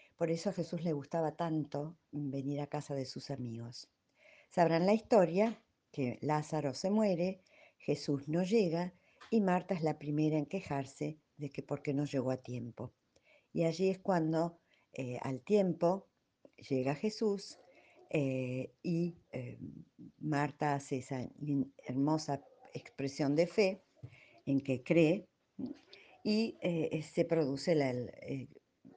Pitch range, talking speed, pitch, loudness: 140-175 Hz, 135 wpm, 155 Hz, -35 LUFS